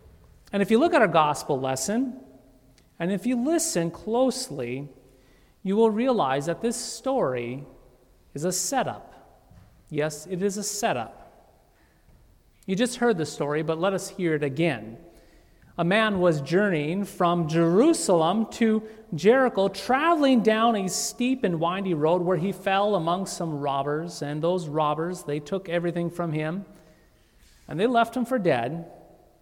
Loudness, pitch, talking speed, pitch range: -25 LUFS, 180 Hz, 150 wpm, 155-225 Hz